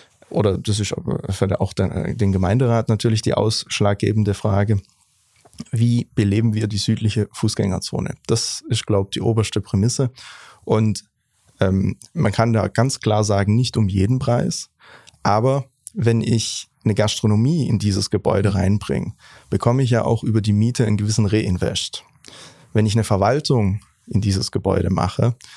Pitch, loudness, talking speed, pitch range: 110 Hz, -20 LUFS, 145 wpm, 100-115 Hz